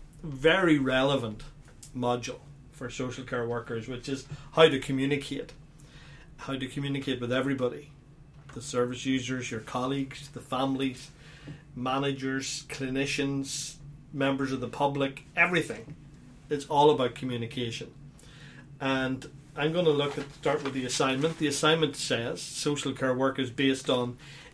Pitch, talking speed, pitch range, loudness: 140 Hz, 135 wpm, 130-145 Hz, -29 LUFS